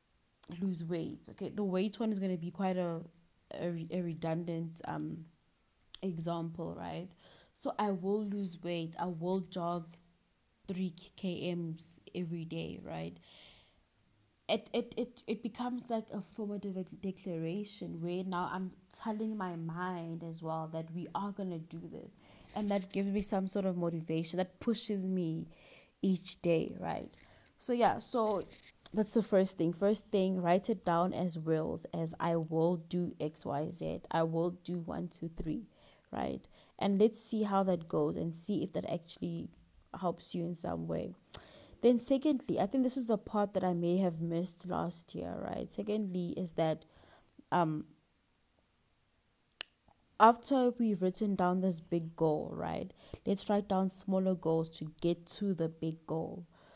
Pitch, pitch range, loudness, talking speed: 180 Hz, 165-200 Hz, -34 LUFS, 160 wpm